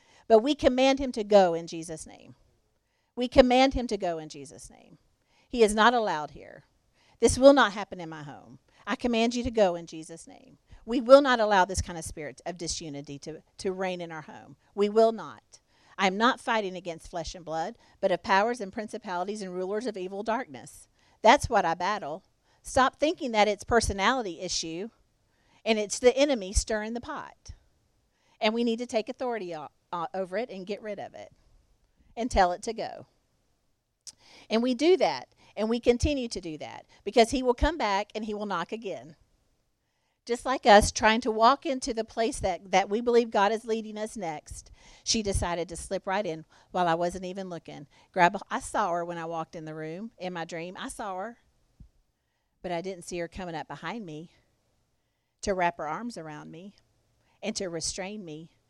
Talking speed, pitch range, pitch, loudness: 195 wpm, 170-230 Hz, 205 Hz, -27 LUFS